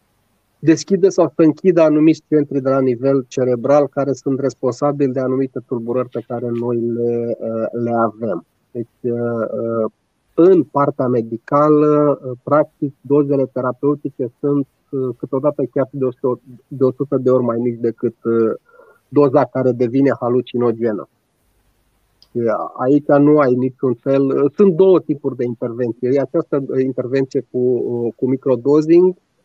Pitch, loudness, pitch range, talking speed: 130 Hz, -17 LUFS, 120-145 Hz, 120 wpm